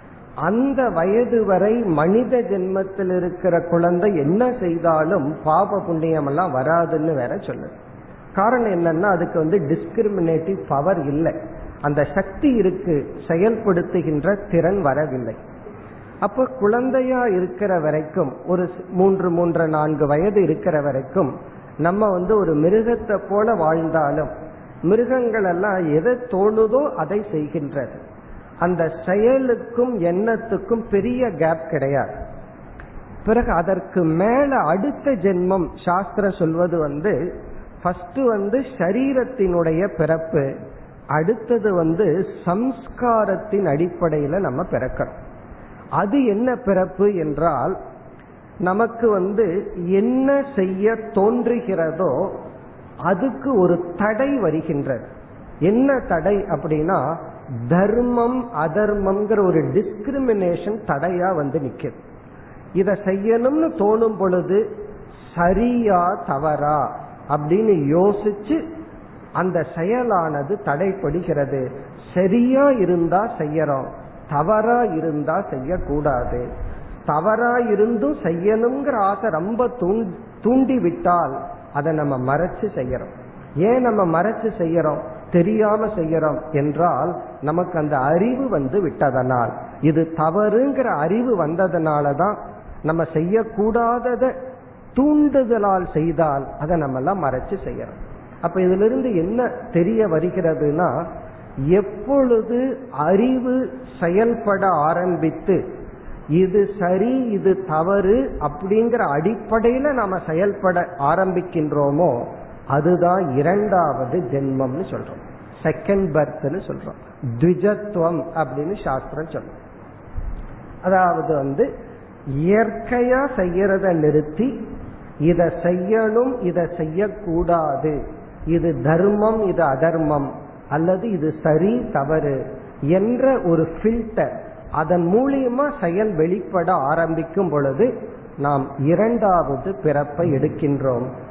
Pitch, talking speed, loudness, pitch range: 180 Hz, 85 wpm, -20 LUFS, 160-215 Hz